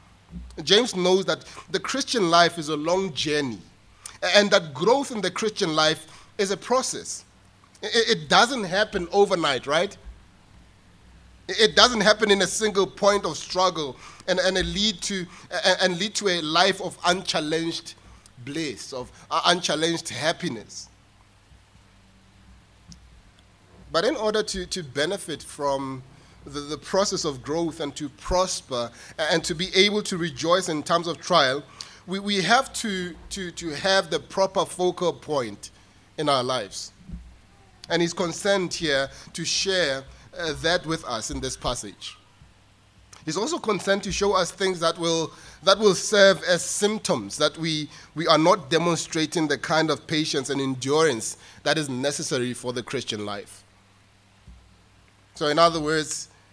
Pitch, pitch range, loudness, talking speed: 165 Hz, 125-190 Hz, -23 LUFS, 140 wpm